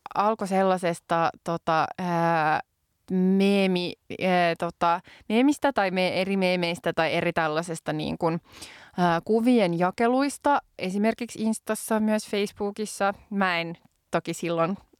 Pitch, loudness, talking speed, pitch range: 185 Hz, -25 LUFS, 95 wpm, 170-210 Hz